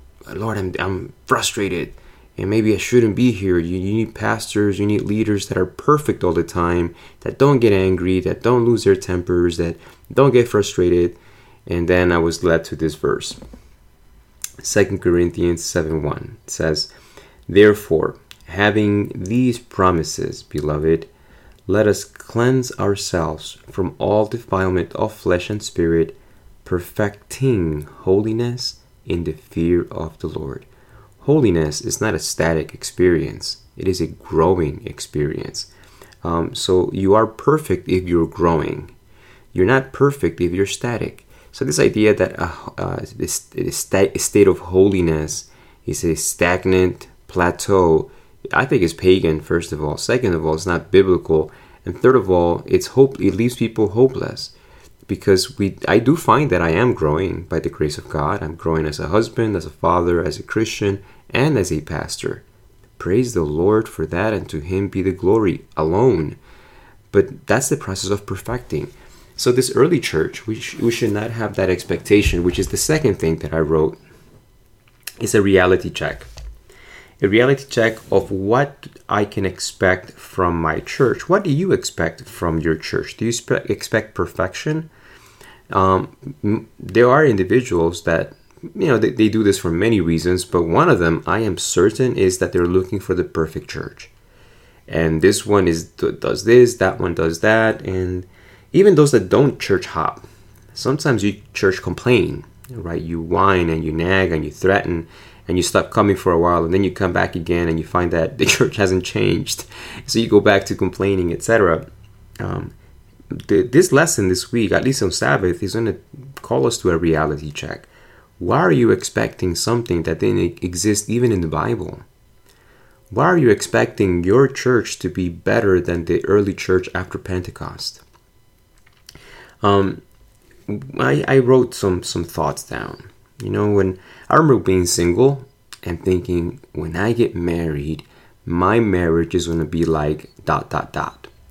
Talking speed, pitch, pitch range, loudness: 165 wpm, 95 Hz, 85-110 Hz, -18 LUFS